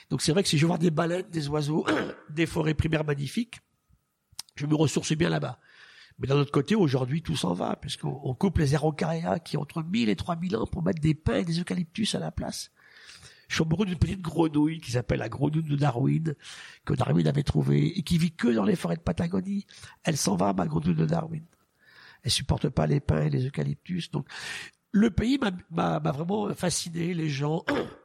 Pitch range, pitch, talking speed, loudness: 150-180 Hz, 165 Hz, 215 wpm, -27 LUFS